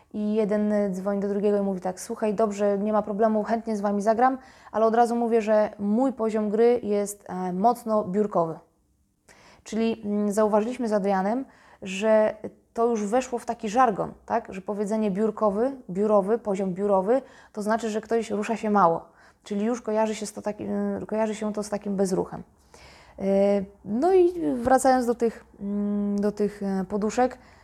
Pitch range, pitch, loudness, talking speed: 205-230 Hz, 215 Hz, -25 LUFS, 160 wpm